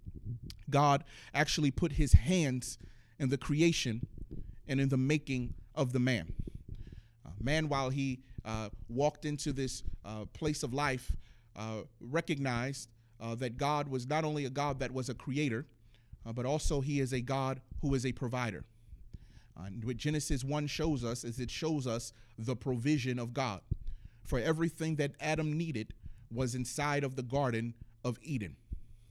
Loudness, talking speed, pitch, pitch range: -35 LUFS, 165 wpm, 130 Hz, 115-145 Hz